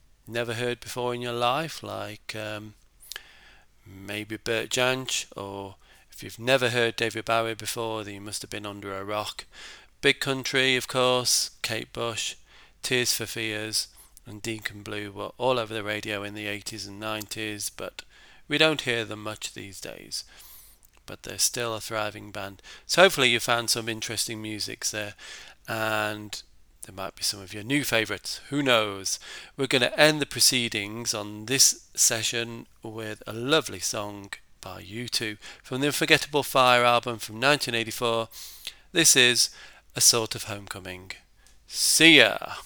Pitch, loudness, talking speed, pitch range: 115 Hz, -24 LUFS, 160 wpm, 105-125 Hz